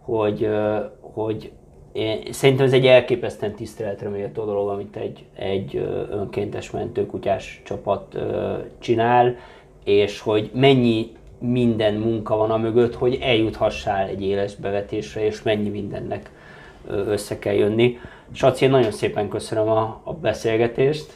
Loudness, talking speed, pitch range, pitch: -22 LUFS, 125 wpm, 105-120 Hz, 110 Hz